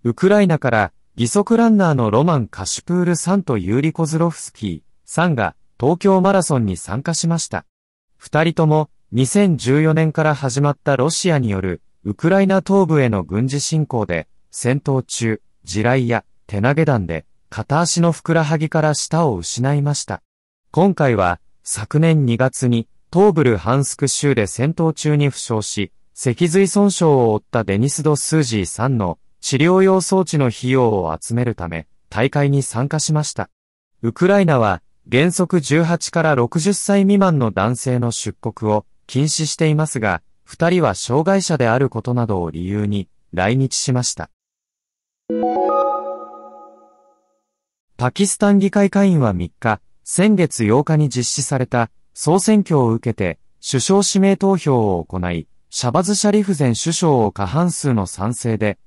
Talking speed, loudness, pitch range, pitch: 290 characters per minute, -17 LUFS, 110-165 Hz, 135 Hz